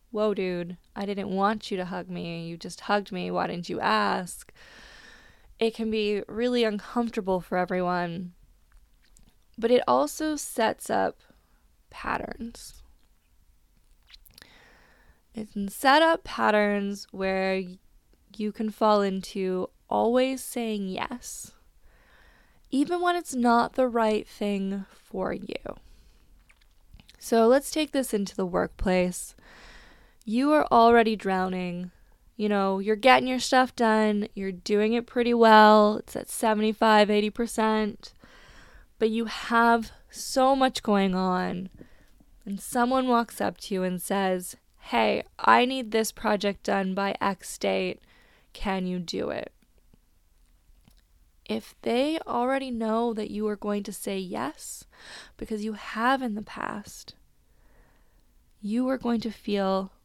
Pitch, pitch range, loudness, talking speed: 210 Hz, 185-235 Hz, -26 LUFS, 130 wpm